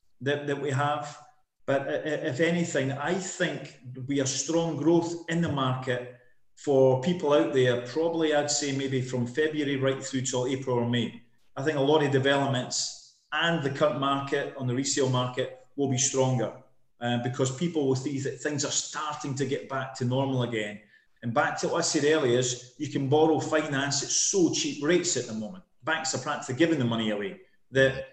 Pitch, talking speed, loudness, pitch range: 140 Hz, 195 wpm, -27 LUFS, 130-155 Hz